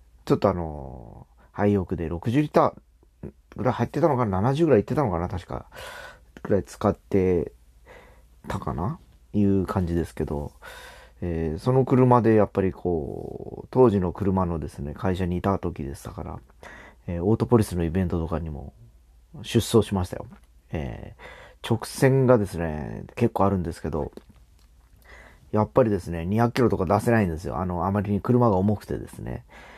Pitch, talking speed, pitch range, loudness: 95 Hz, 320 characters per minute, 85-115 Hz, -24 LUFS